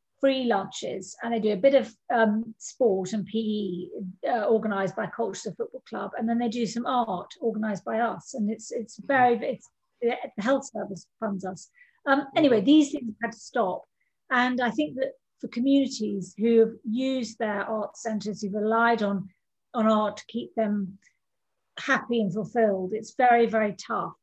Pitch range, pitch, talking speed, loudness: 210-250 Hz, 225 Hz, 180 wpm, -26 LUFS